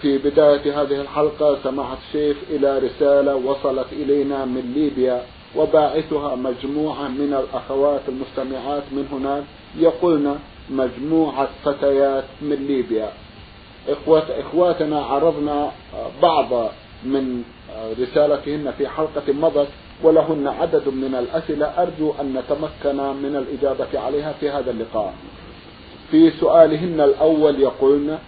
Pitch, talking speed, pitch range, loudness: 145 Hz, 105 wpm, 135-150 Hz, -20 LUFS